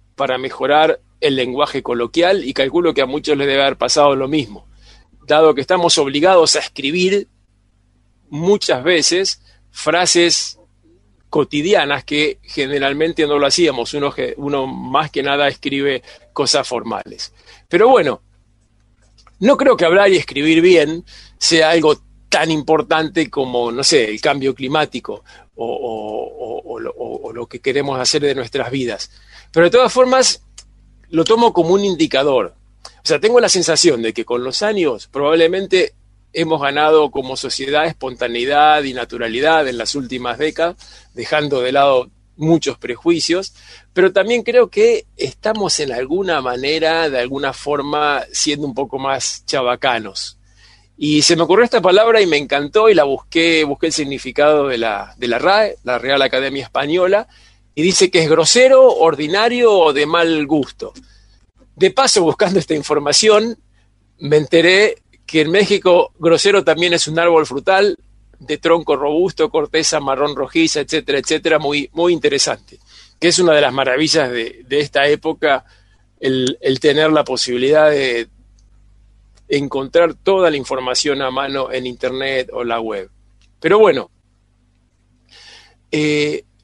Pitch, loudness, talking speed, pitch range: 145 Hz, -15 LUFS, 150 wpm, 125-165 Hz